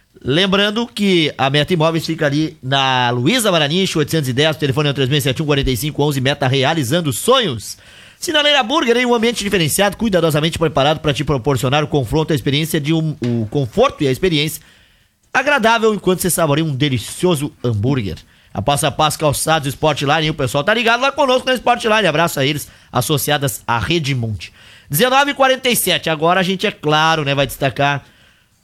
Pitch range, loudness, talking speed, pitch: 135-180 Hz, -16 LUFS, 165 wpm, 150 Hz